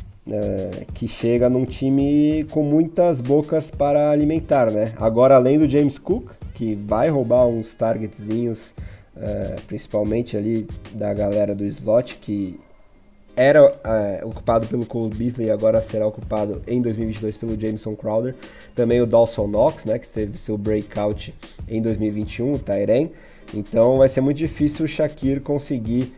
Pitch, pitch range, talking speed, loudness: 115 Hz, 105-135 Hz, 150 wpm, -20 LUFS